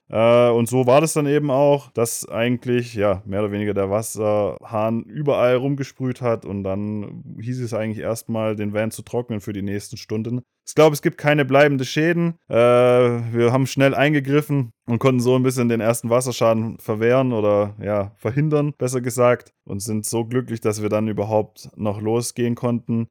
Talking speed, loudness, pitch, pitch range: 175 wpm, -20 LUFS, 120 Hz, 110-130 Hz